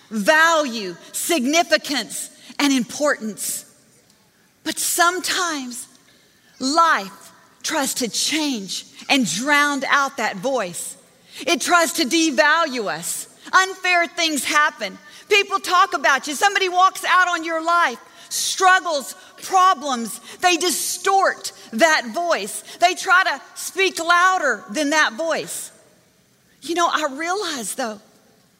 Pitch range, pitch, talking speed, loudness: 255-350 Hz, 310 Hz, 110 wpm, -19 LUFS